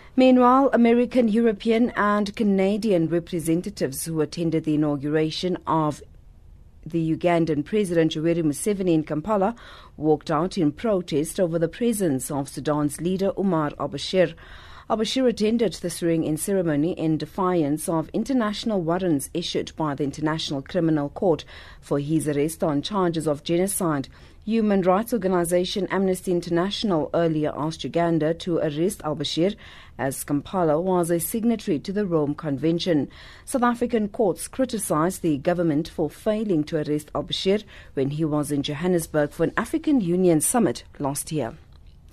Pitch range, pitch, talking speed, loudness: 150-195 Hz, 170 Hz, 140 wpm, -23 LUFS